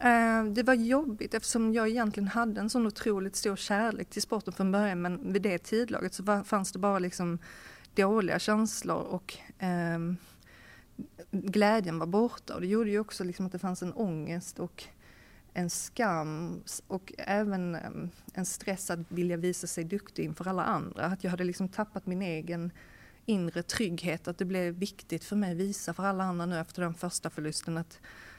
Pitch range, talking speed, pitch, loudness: 175-210 Hz, 175 wpm, 190 Hz, -32 LUFS